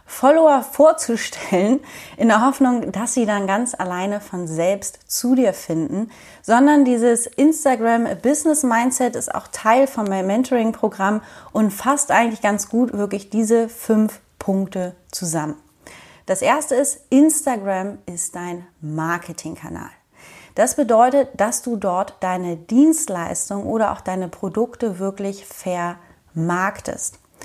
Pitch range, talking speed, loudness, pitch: 190-250 Hz, 125 wpm, -19 LUFS, 215 Hz